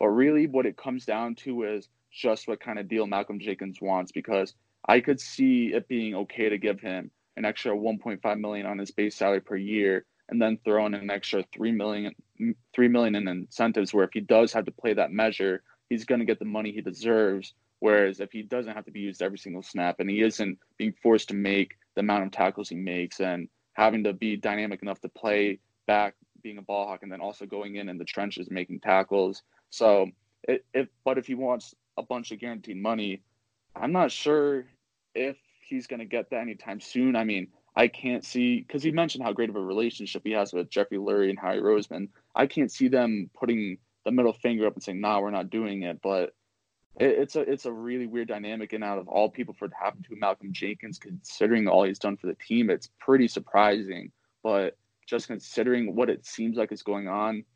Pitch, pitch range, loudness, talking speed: 105 Hz, 100-120 Hz, -28 LUFS, 225 wpm